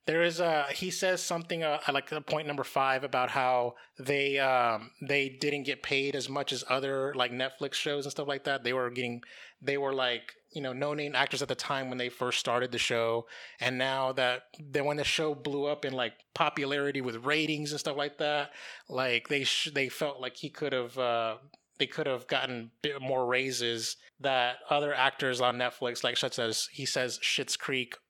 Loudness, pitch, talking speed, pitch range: -31 LUFS, 135 Hz, 205 wpm, 125-145 Hz